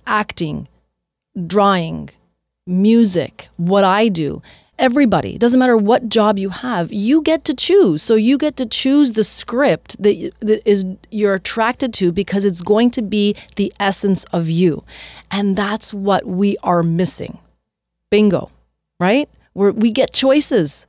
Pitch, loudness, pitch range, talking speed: 205 Hz, -16 LUFS, 190-235 Hz, 140 wpm